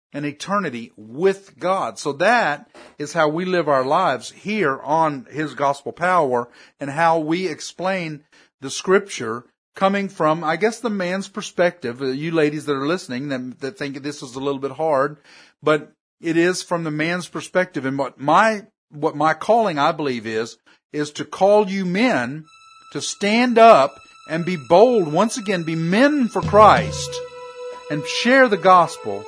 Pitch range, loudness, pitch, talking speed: 145-200 Hz, -19 LUFS, 165 Hz, 165 wpm